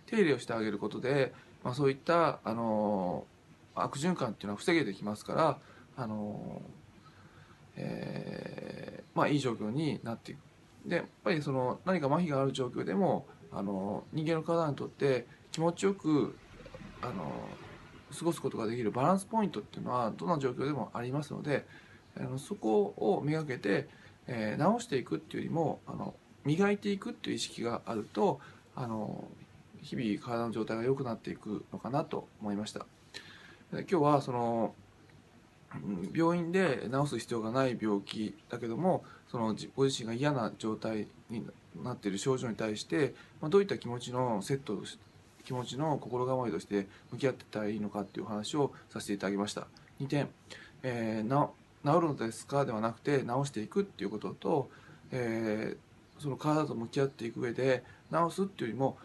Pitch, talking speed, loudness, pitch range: 125 Hz, 345 characters per minute, -34 LUFS, 110-150 Hz